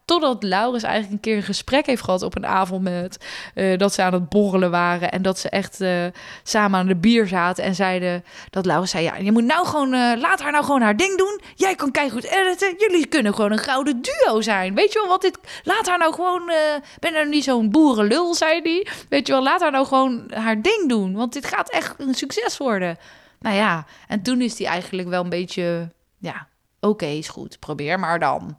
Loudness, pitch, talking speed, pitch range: -20 LUFS, 230 Hz, 235 wpm, 190-305 Hz